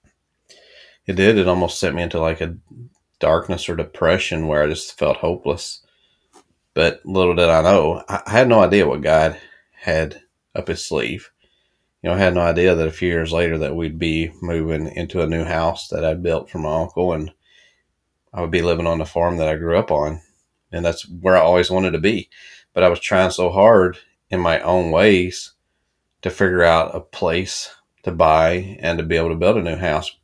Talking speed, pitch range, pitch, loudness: 205 wpm, 80-90 Hz, 85 Hz, -18 LUFS